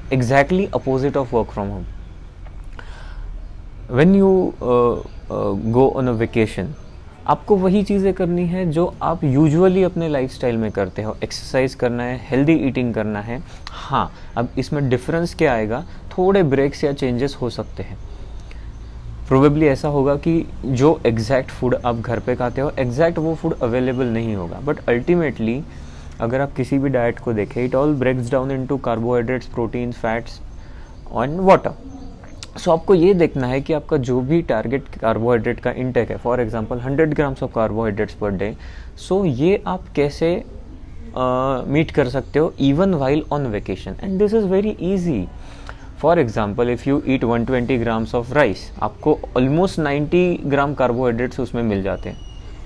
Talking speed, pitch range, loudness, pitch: 160 wpm, 110-150 Hz, -19 LUFS, 125 Hz